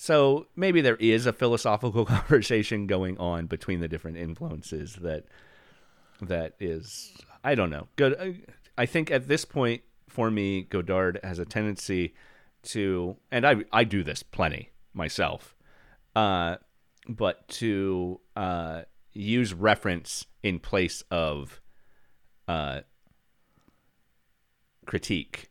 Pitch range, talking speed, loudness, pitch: 85-115 Hz, 120 wpm, -28 LUFS, 100 Hz